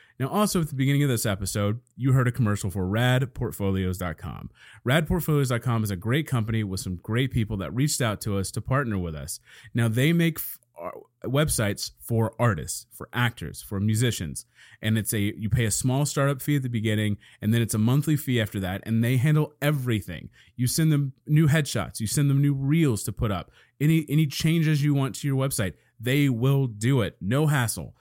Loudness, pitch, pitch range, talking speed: -25 LUFS, 120 Hz, 105-140 Hz, 205 wpm